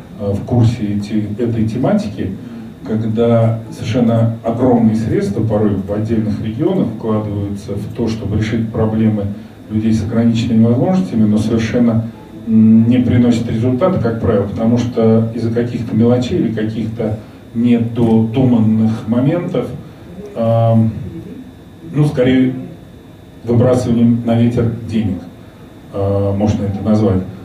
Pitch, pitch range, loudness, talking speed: 115 Hz, 110-120 Hz, -15 LUFS, 110 wpm